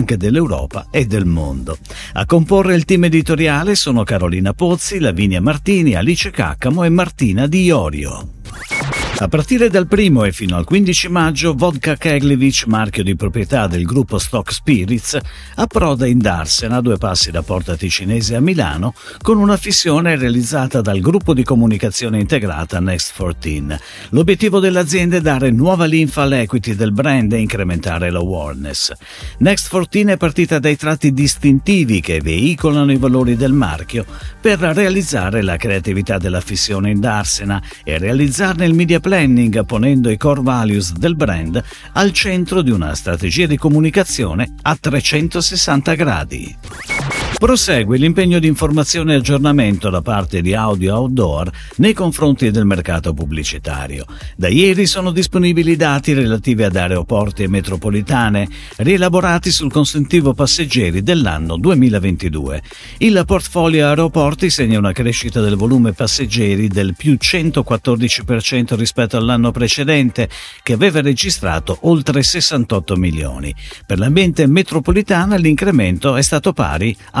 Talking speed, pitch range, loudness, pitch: 135 wpm, 100-160 Hz, -14 LUFS, 125 Hz